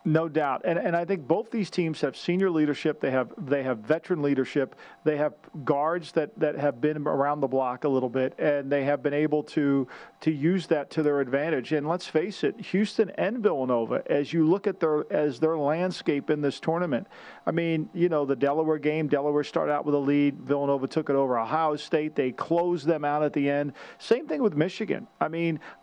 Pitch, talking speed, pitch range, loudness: 150 Hz, 215 wpm, 145-165 Hz, -27 LUFS